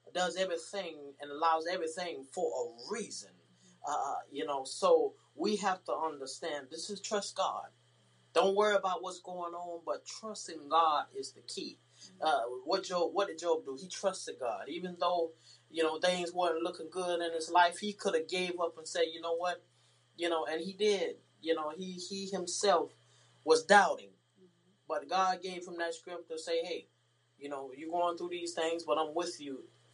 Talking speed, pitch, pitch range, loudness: 190 wpm, 175 Hz, 160-185 Hz, -34 LUFS